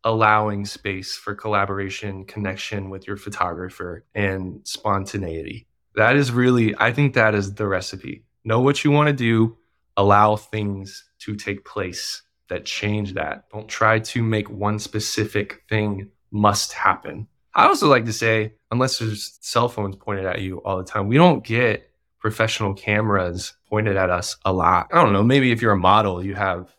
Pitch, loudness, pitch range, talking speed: 105 Hz, -21 LUFS, 100-110 Hz, 175 wpm